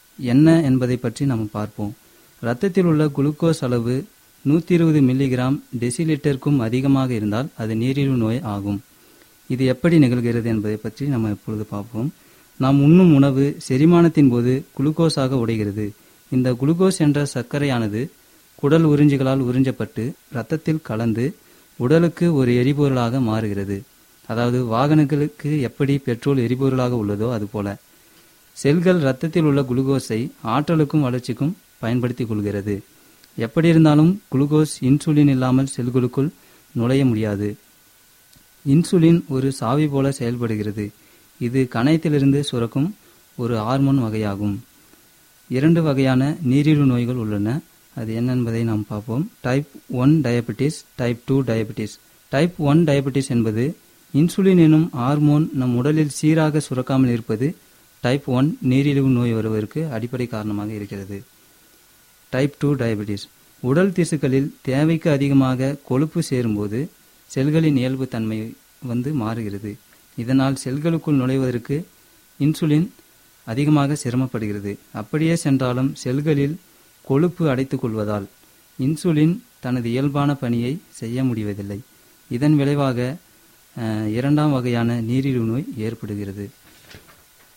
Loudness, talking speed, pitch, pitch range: -20 LUFS, 110 wpm, 135 Hz, 115-150 Hz